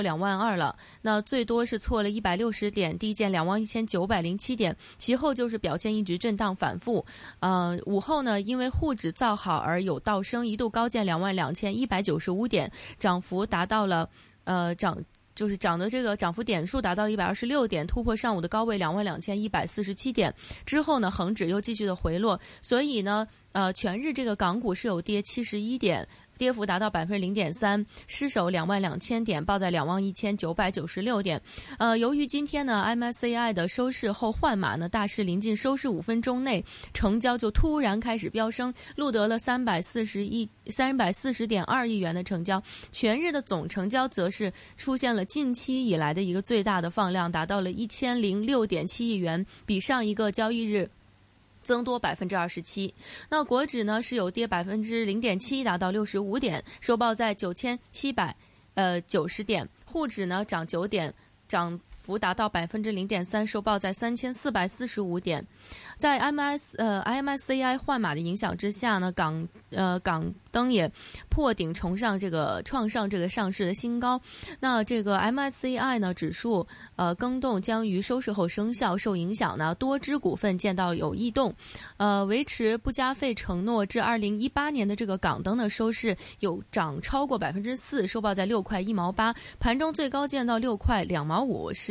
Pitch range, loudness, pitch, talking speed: 185-240 Hz, -28 LUFS, 215 Hz, 290 characters per minute